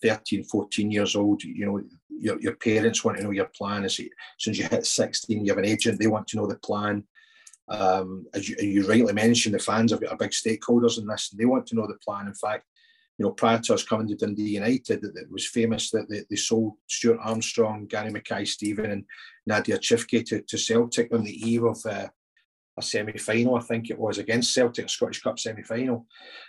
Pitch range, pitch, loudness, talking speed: 105-115 Hz, 110 Hz, -26 LUFS, 220 wpm